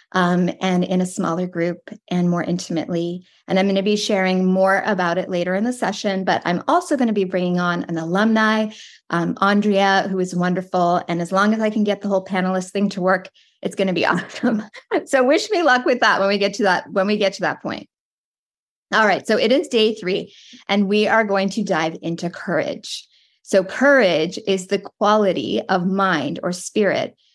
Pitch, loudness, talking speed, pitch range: 190 Hz, -19 LUFS, 210 wpm, 180-210 Hz